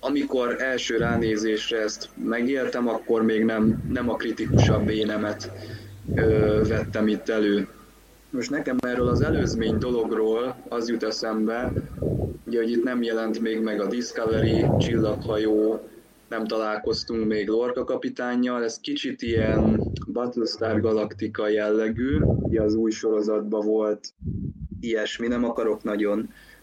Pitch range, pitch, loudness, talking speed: 110-115 Hz, 110 Hz, -25 LUFS, 120 wpm